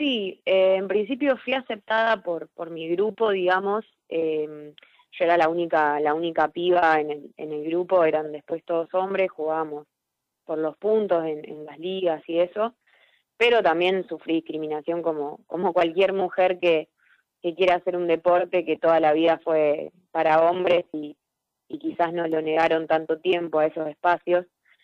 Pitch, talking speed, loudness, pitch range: 170 Hz, 170 wpm, -24 LUFS, 155-185 Hz